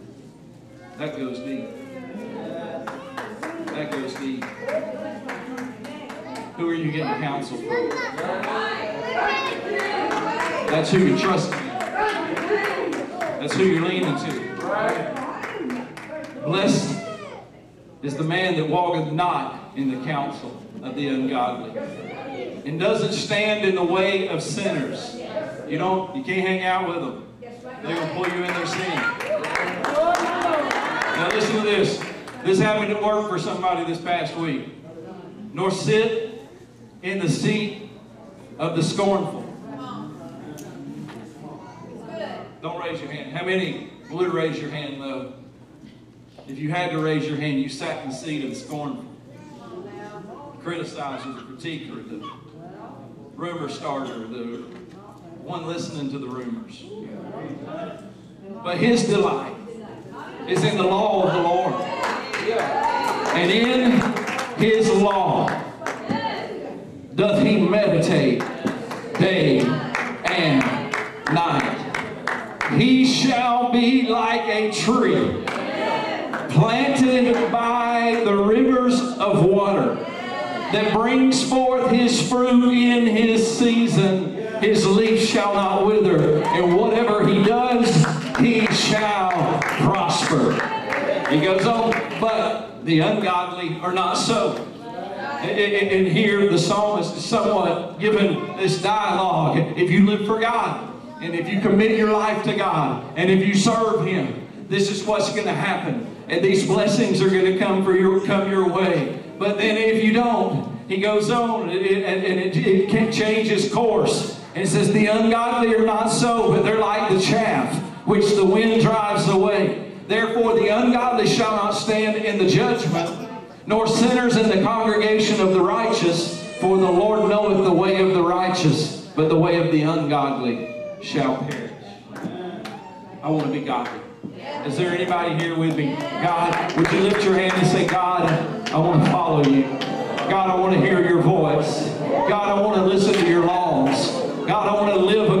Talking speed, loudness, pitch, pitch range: 140 wpm, -20 LUFS, 200 Hz, 175-225 Hz